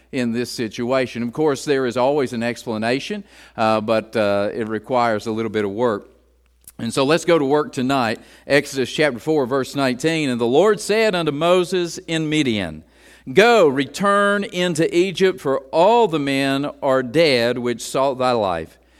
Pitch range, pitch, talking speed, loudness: 115-160 Hz, 135 Hz, 170 wpm, -19 LUFS